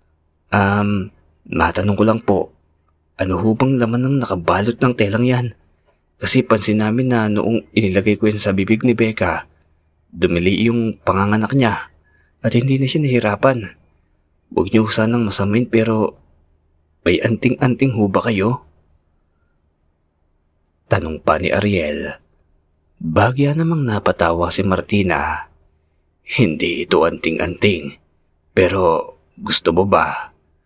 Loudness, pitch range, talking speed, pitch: -17 LUFS, 80-115 Hz, 120 wpm, 100 Hz